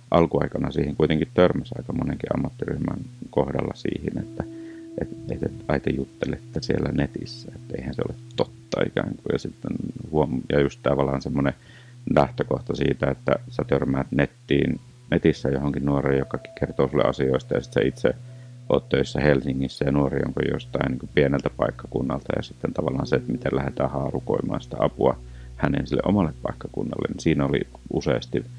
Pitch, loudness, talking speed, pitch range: 70 Hz, -25 LUFS, 155 wpm, 65-80 Hz